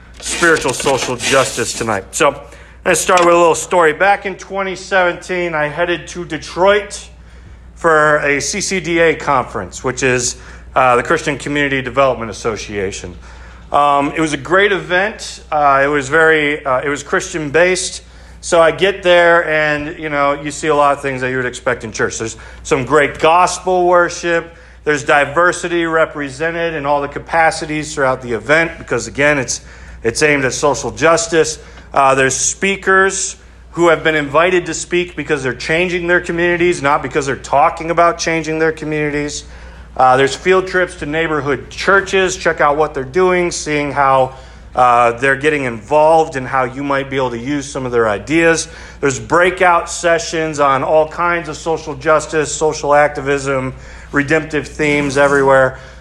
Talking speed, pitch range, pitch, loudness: 165 wpm, 135-170 Hz, 150 Hz, -14 LUFS